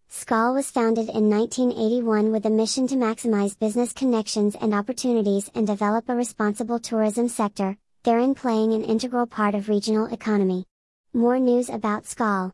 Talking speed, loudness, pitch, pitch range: 155 wpm, -23 LUFS, 220 Hz, 210-240 Hz